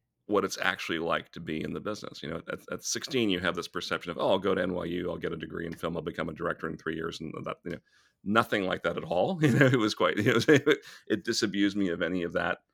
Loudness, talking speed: -29 LUFS, 285 wpm